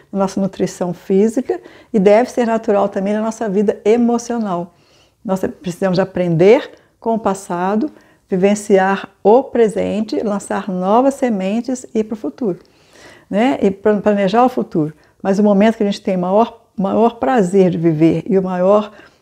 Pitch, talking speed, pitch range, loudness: 205 Hz, 155 wpm, 190-225 Hz, -16 LUFS